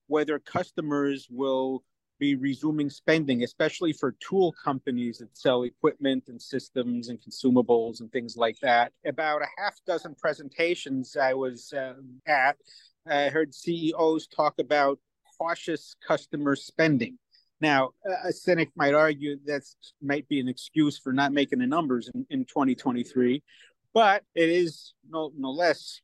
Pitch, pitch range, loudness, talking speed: 145 Hz, 130-160 Hz, -27 LUFS, 145 wpm